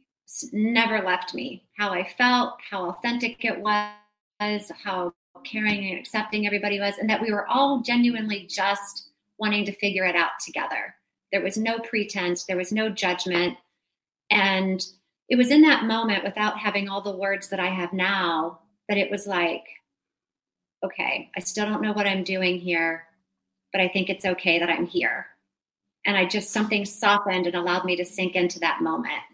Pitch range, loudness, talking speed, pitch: 180-210 Hz, -24 LUFS, 175 wpm, 200 Hz